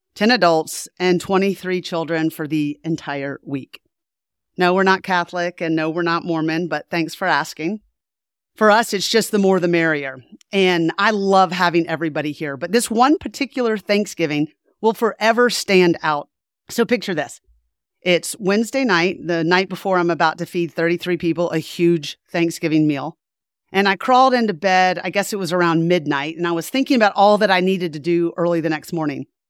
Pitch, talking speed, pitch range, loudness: 175 Hz, 185 wpm, 160-195 Hz, -18 LUFS